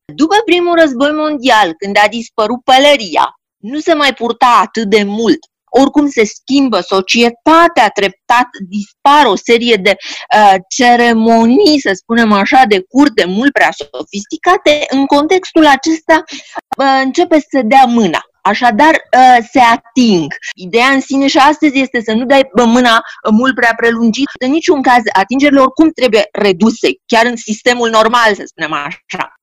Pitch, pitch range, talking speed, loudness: 250 Hz, 225-290 Hz, 150 wpm, -10 LUFS